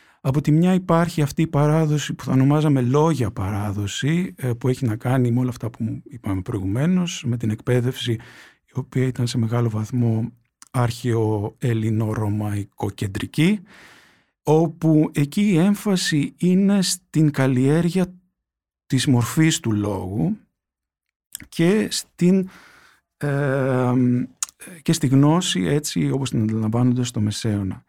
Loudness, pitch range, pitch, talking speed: -21 LUFS, 115-160 Hz, 130 Hz, 120 wpm